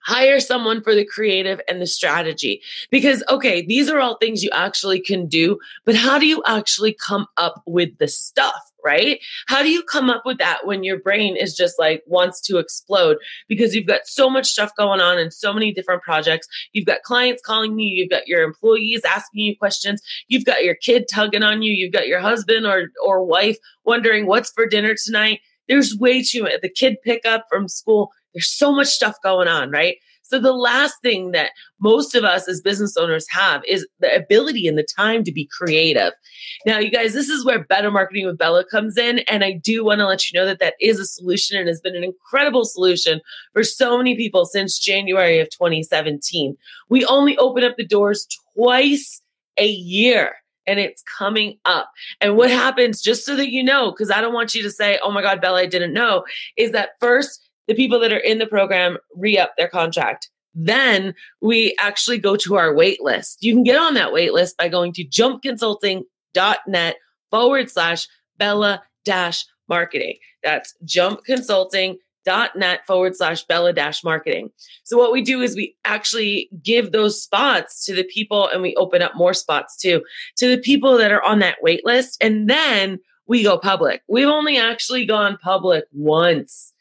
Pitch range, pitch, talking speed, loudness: 185-250 Hz, 210 Hz, 200 wpm, -17 LUFS